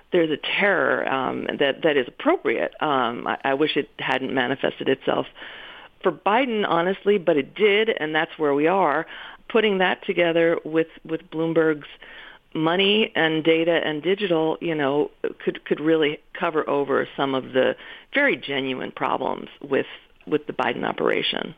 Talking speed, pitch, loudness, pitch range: 155 wpm, 160 Hz, -22 LUFS, 150-195 Hz